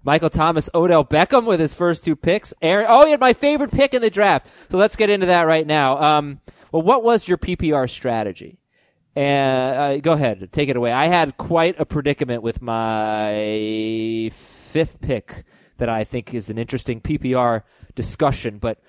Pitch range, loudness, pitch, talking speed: 115-165 Hz, -18 LUFS, 145 Hz, 185 wpm